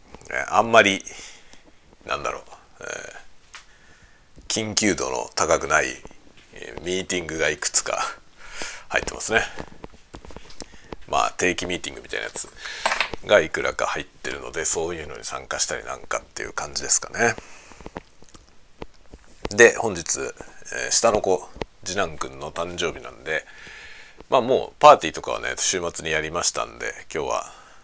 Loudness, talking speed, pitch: -22 LUFS, 290 characters per minute, 275 Hz